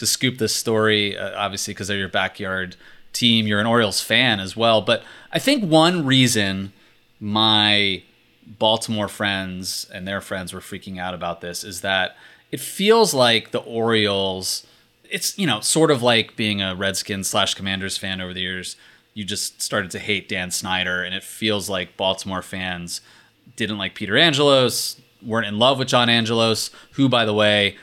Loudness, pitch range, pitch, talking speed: -20 LUFS, 95-115 Hz, 105 Hz, 175 wpm